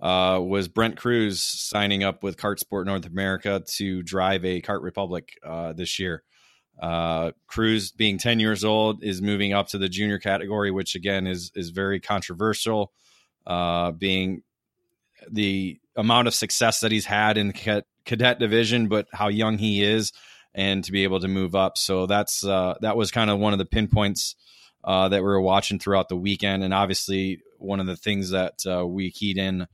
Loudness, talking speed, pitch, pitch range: -24 LUFS, 190 wpm, 100 Hz, 95-105 Hz